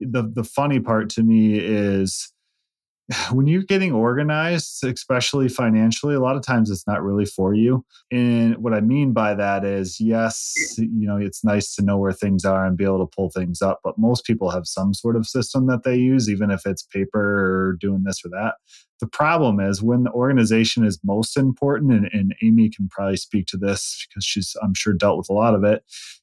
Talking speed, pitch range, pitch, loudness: 215 wpm, 100-125 Hz, 110 Hz, -20 LUFS